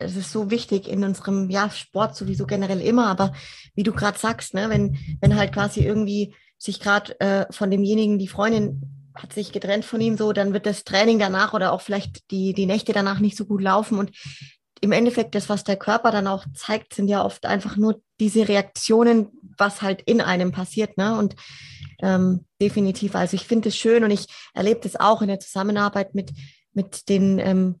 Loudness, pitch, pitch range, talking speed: -22 LUFS, 200 Hz, 190-215 Hz, 205 wpm